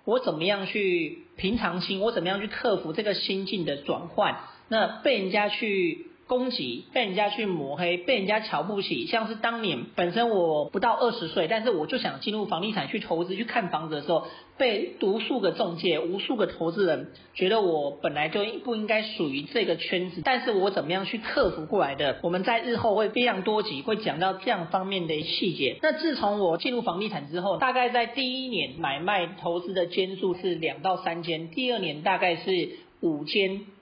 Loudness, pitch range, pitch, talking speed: -27 LUFS, 180-235 Hz, 205 Hz, 300 characters per minute